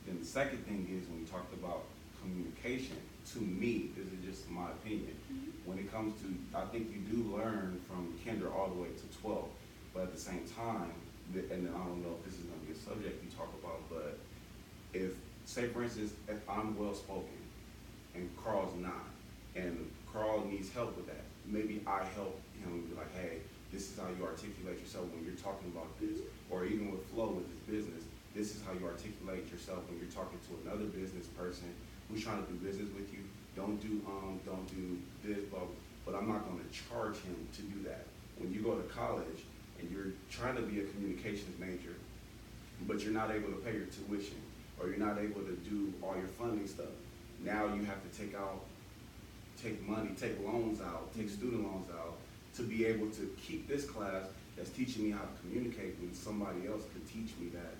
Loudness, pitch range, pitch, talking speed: -42 LUFS, 90-105 Hz, 100 Hz, 205 wpm